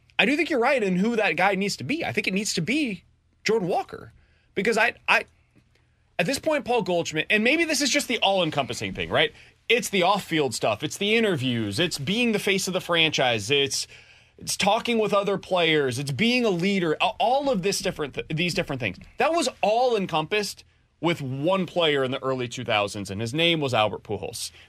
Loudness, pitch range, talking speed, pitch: -24 LUFS, 150-220 Hz, 210 wpm, 185 Hz